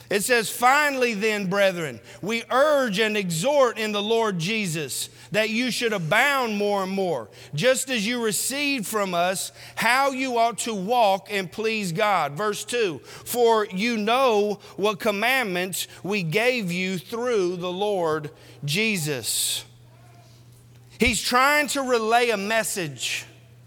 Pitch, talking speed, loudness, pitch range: 210 Hz, 135 wpm, -23 LUFS, 170-235 Hz